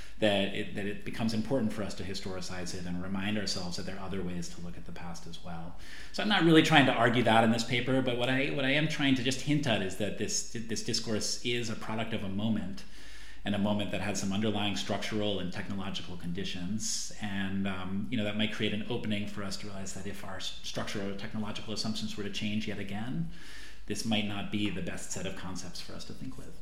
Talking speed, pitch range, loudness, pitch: 245 wpm, 100-115 Hz, -32 LUFS, 105 Hz